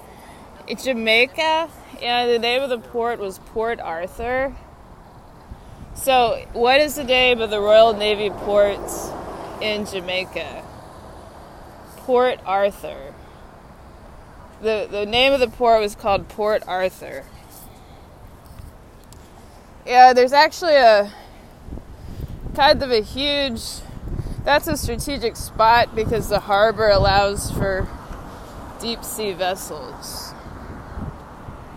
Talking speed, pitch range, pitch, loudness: 105 wpm, 205-255 Hz, 230 Hz, -19 LUFS